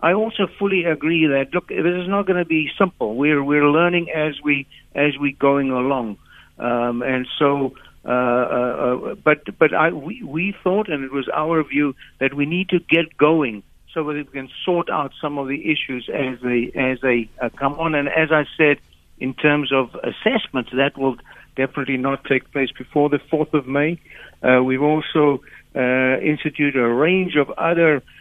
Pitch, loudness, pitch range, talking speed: 145 Hz, -20 LUFS, 130-160 Hz, 185 wpm